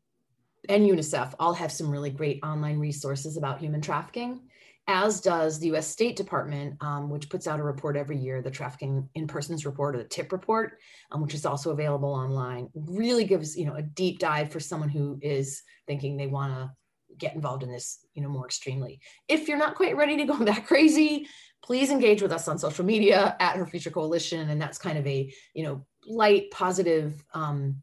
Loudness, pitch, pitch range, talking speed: -27 LUFS, 155 Hz, 140-190 Hz, 205 wpm